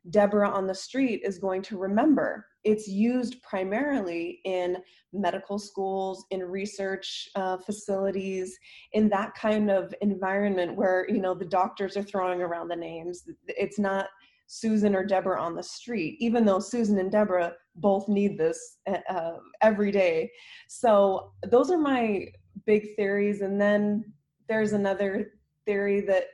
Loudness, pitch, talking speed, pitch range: -27 LUFS, 200 Hz, 145 wpm, 190-215 Hz